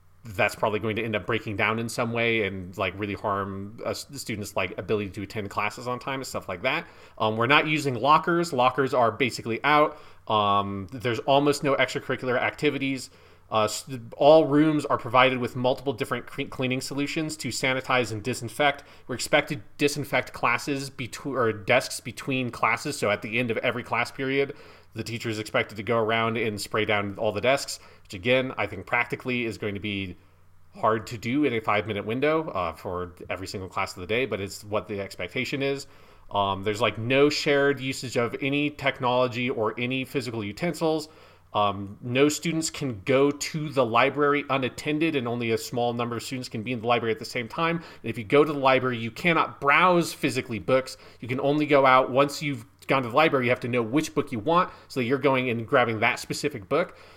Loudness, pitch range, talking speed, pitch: -25 LUFS, 110-140 Hz, 210 wpm, 125 Hz